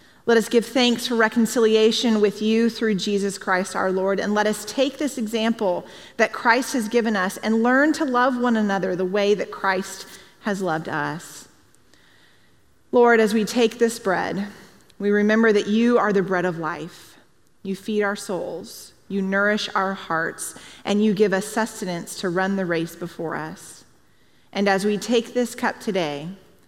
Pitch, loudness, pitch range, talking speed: 210 Hz, -22 LUFS, 190-230 Hz, 175 wpm